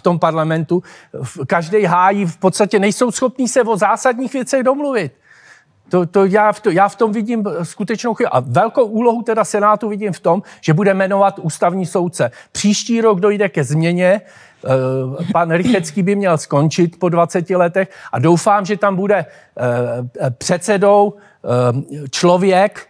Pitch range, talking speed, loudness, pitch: 170-210 Hz, 150 wpm, -15 LUFS, 195 Hz